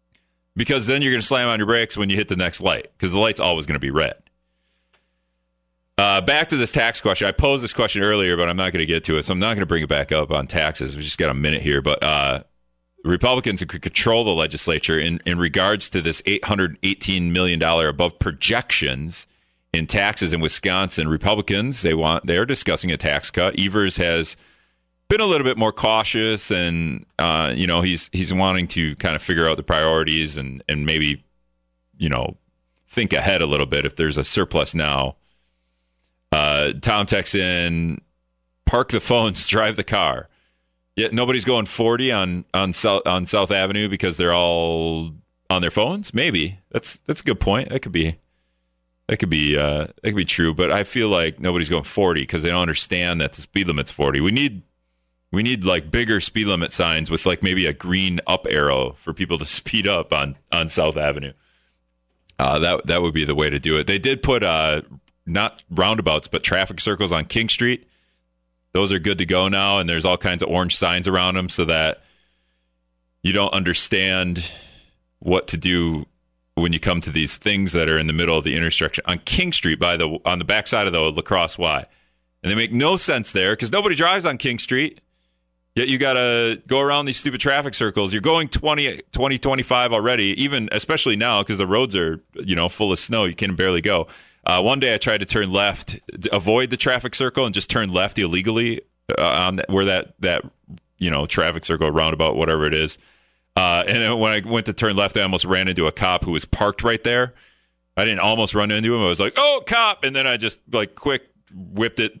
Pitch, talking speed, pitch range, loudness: 90 Hz, 210 wpm, 75-105 Hz, -19 LUFS